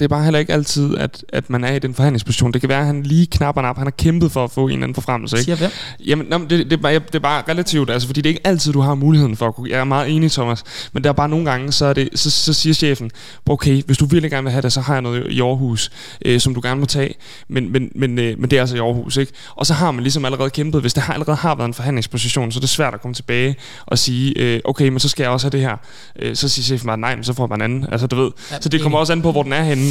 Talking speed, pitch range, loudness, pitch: 310 wpm, 125-150 Hz, -17 LUFS, 135 Hz